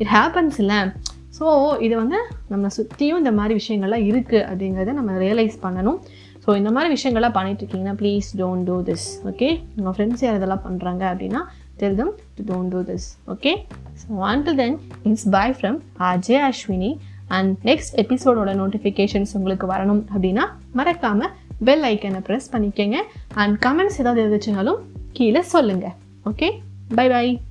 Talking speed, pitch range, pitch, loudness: 140 wpm, 190-245 Hz, 210 Hz, -20 LUFS